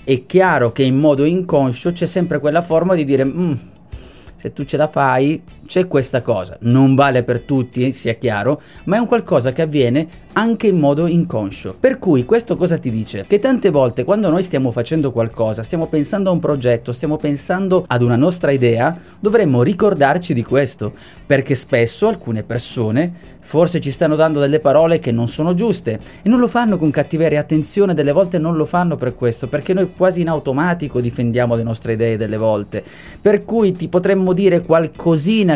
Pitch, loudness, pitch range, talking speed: 150 Hz, -16 LUFS, 125-180 Hz, 185 wpm